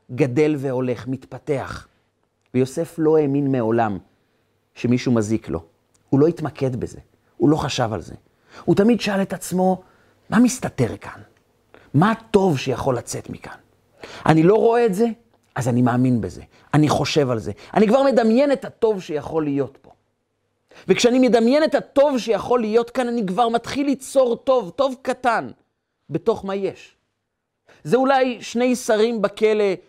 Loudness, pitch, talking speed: -20 LUFS, 155 Hz, 150 wpm